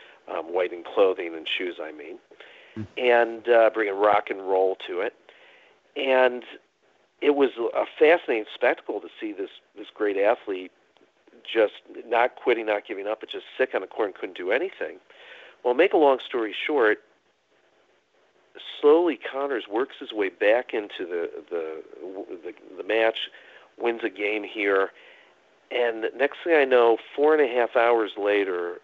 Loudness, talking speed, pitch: -24 LUFS, 165 wpm, 375 Hz